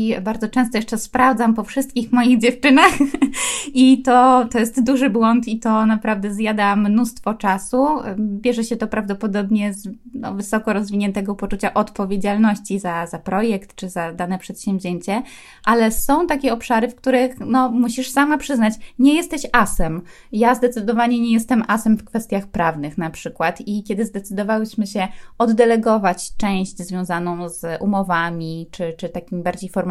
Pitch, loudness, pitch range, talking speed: 220 Hz, -19 LUFS, 195-245 Hz, 150 wpm